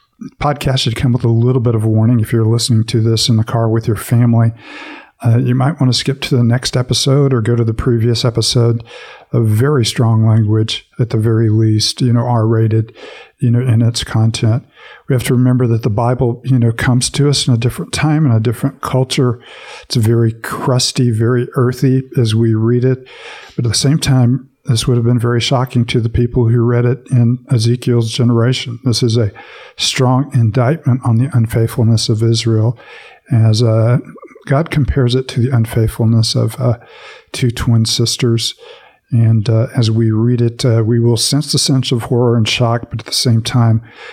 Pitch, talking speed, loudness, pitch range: 120 Hz, 200 wpm, -14 LUFS, 115-130 Hz